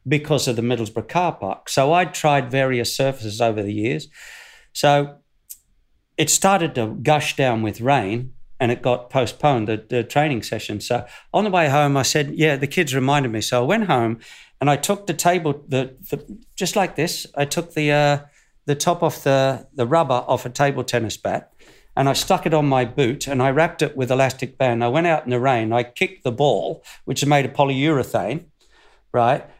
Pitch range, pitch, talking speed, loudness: 125-155 Hz, 140 Hz, 205 wpm, -20 LUFS